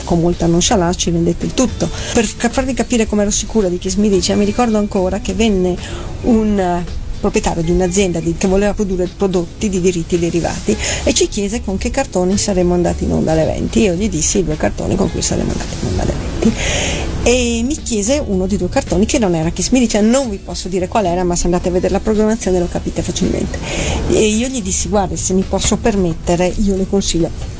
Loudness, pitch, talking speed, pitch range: -16 LUFS, 195 Hz, 210 wpm, 180-215 Hz